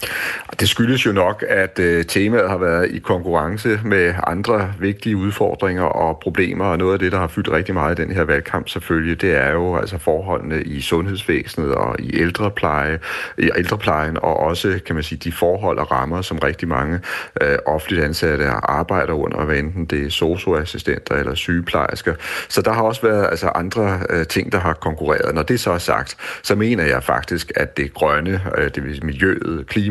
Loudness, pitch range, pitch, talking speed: -19 LUFS, 80-95 Hz, 85 Hz, 195 wpm